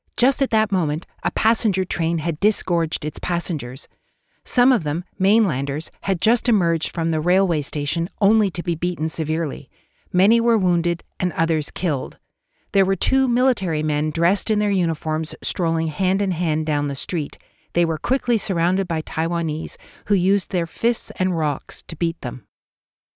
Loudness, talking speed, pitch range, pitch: -21 LUFS, 165 wpm, 160-200 Hz, 175 Hz